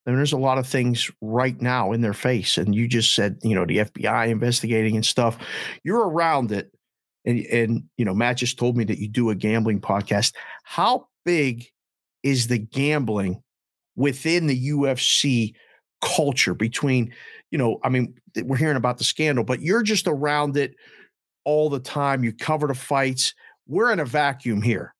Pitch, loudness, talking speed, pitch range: 125 Hz, -22 LUFS, 185 wpm, 110-140 Hz